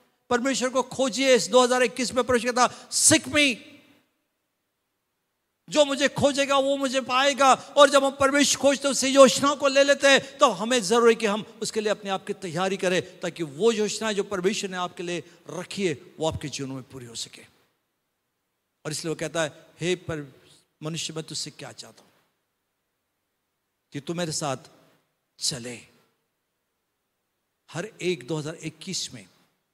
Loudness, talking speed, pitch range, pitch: -23 LUFS, 155 wpm, 160-265 Hz, 200 Hz